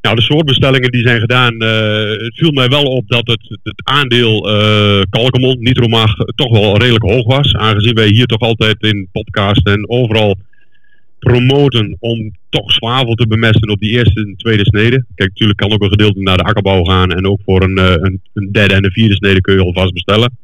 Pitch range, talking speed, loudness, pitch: 100-120 Hz, 210 wpm, -11 LUFS, 110 Hz